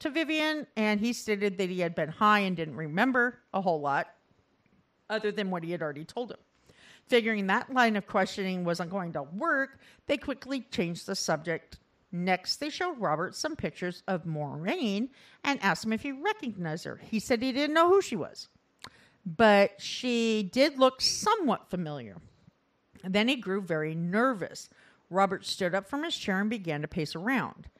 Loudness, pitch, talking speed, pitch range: -29 LUFS, 205 Hz, 180 wpm, 180-255 Hz